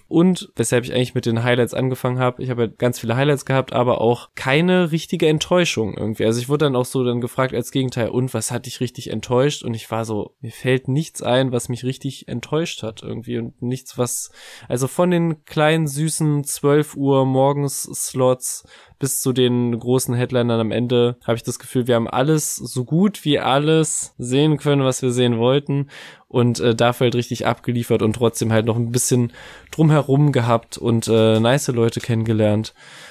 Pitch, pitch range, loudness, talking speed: 125 Hz, 120-140 Hz, -19 LUFS, 195 wpm